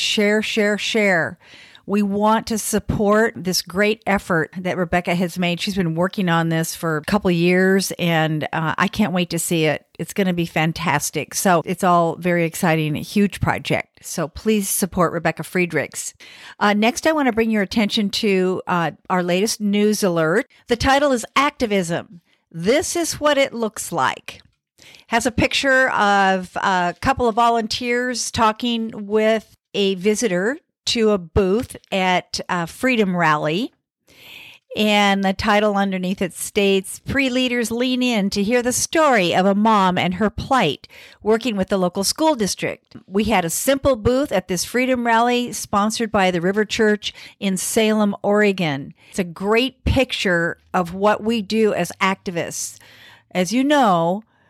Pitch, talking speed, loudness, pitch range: 200 Hz, 165 wpm, -19 LUFS, 180-225 Hz